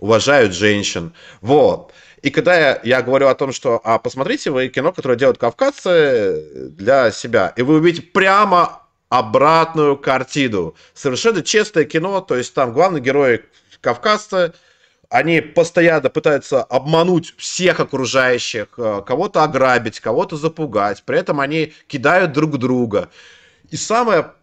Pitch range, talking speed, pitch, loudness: 130-175 Hz, 130 wpm, 155 Hz, -16 LUFS